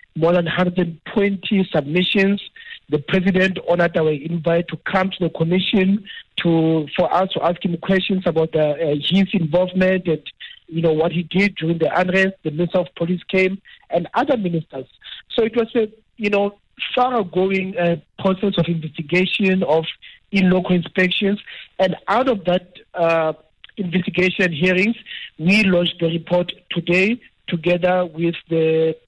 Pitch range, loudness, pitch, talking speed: 170-195 Hz, -19 LUFS, 180 Hz, 155 wpm